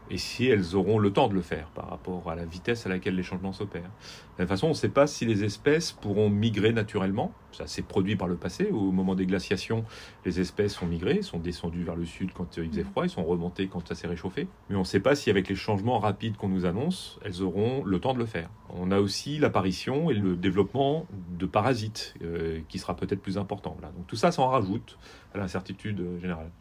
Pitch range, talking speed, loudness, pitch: 90-105 Hz, 240 wpm, -29 LUFS, 95 Hz